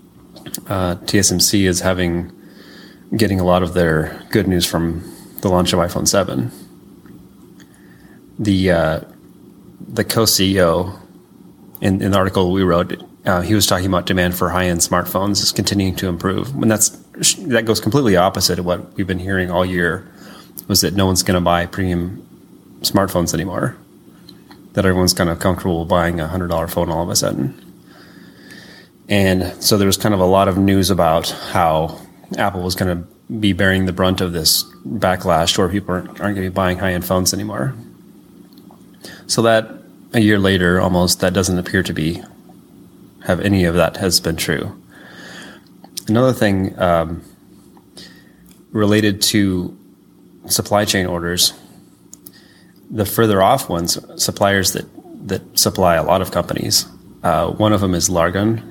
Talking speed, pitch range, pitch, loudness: 155 wpm, 90-100 Hz, 95 Hz, -17 LUFS